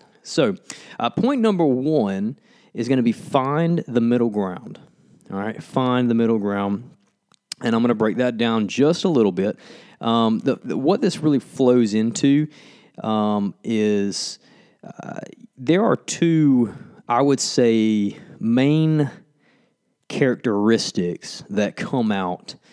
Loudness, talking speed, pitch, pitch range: -21 LUFS, 135 wpm, 125 Hz, 110-155 Hz